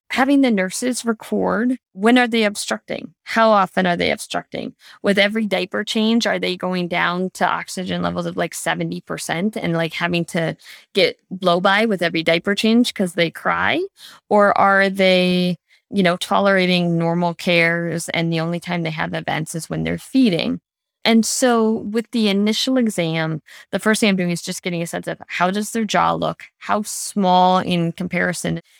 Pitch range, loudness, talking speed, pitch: 170-220 Hz, -19 LUFS, 180 wpm, 185 Hz